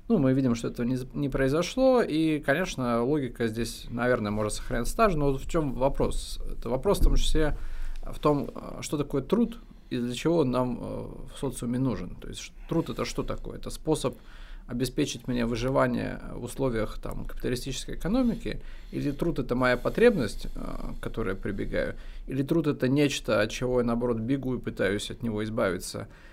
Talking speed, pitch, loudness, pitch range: 175 wpm, 130 Hz, -28 LUFS, 120-150 Hz